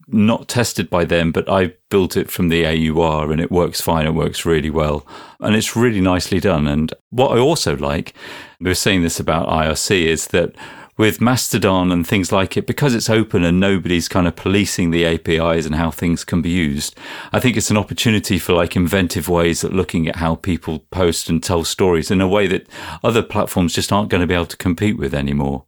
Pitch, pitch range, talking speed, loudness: 85 Hz, 80-100 Hz, 210 wpm, -17 LUFS